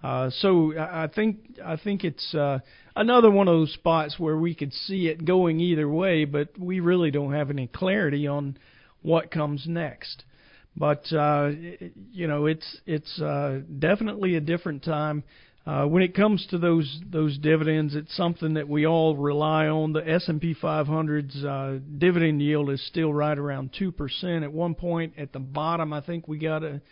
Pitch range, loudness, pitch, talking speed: 150-170 Hz, -25 LUFS, 155 Hz, 185 wpm